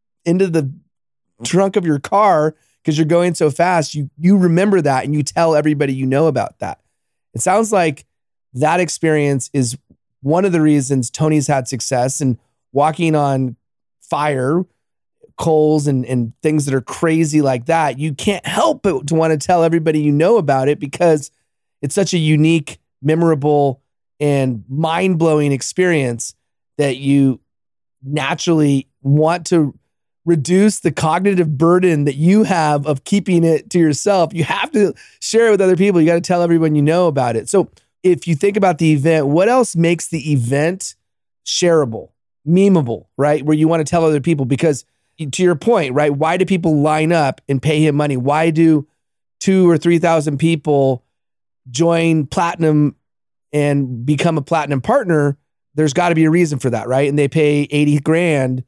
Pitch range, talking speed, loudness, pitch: 140-170 Hz, 170 wpm, -15 LUFS, 155 Hz